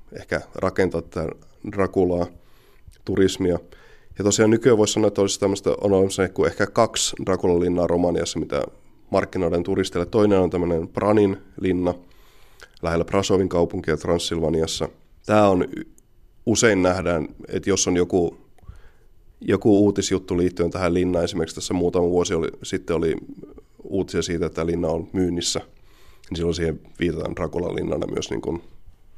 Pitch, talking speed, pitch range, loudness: 90 Hz, 140 wpm, 85-95 Hz, -22 LUFS